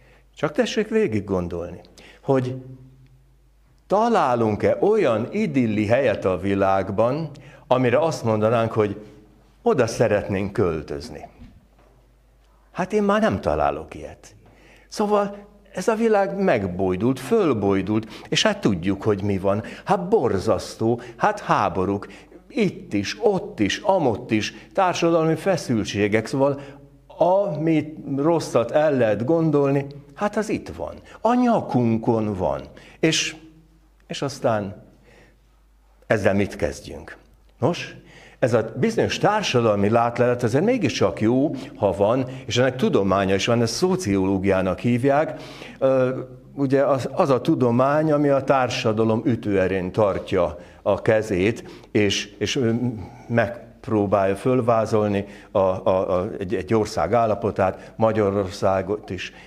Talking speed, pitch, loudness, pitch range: 110 wpm, 120 Hz, -22 LUFS, 105-155 Hz